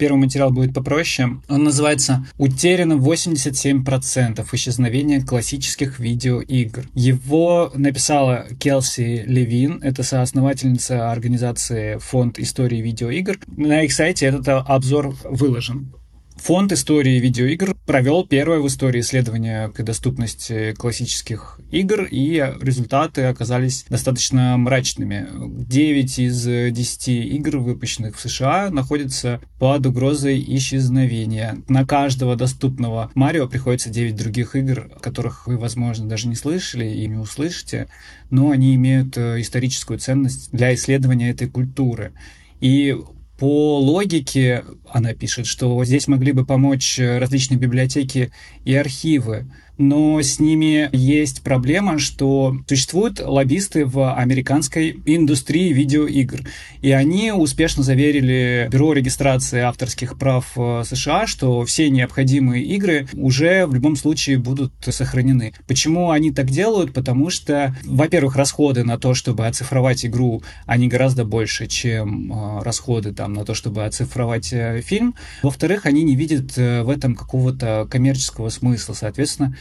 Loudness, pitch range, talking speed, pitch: -18 LUFS, 120-140 Hz, 120 wpm, 130 Hz